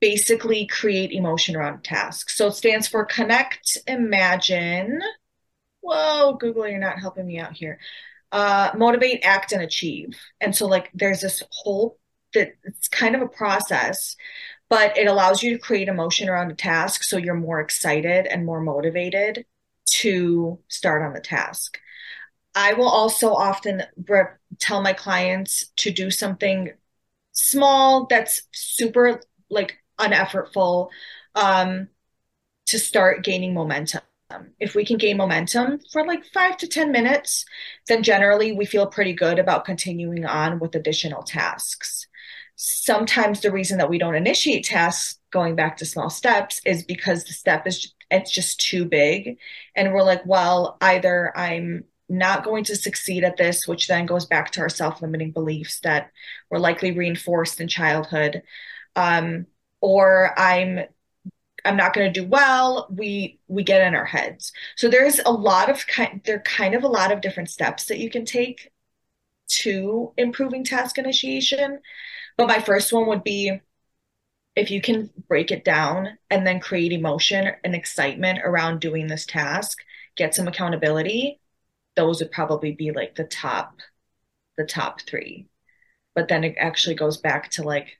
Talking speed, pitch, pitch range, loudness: 155 wpm, 195 Hz, 175-225 Hz, -21 LUFS